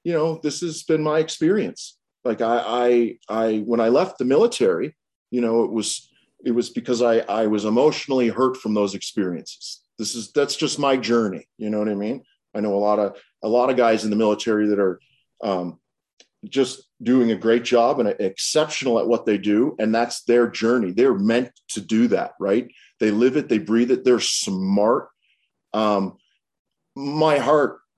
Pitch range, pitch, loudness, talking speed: 110-130 Hz, 115 Hz, -21 LUFS, 190 wpm